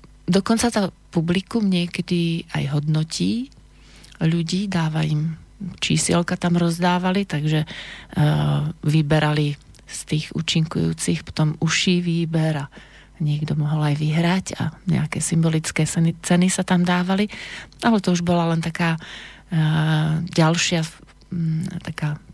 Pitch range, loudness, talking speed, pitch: 155-180 Hz, -21 LUFS, 120 wpm, 165 Hz